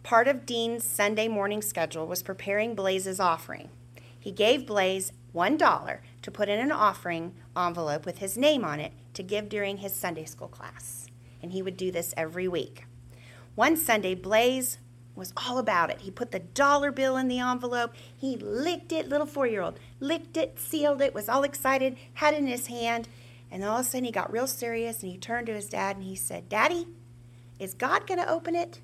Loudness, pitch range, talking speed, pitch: -28 LUFS, 160-250 Hz, 205 wpm, 205 Hz